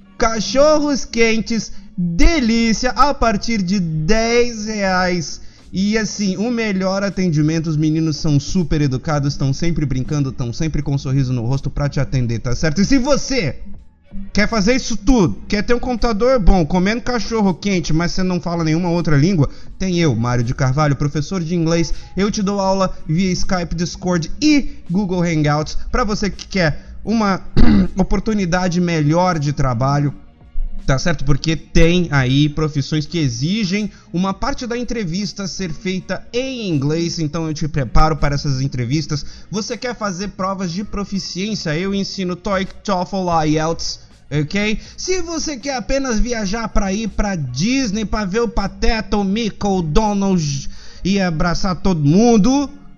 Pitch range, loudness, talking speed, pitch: 155-215 Hz, -18 LUFS, 155 wpm, 185 Hz